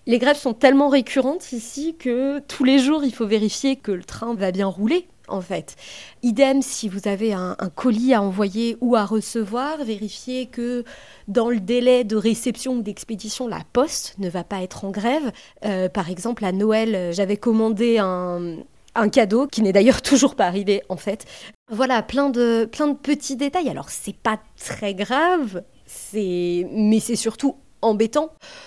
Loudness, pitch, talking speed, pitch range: -21 LUFS, 230 Hz, 180 wpm, 205-265 Hz